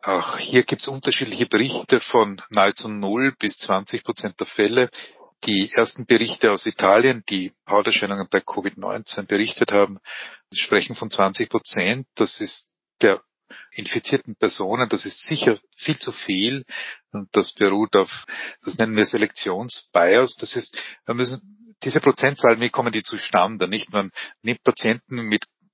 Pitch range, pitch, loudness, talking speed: 105-130 Hz, 115 Hz, -21 LUFS, 145 wpm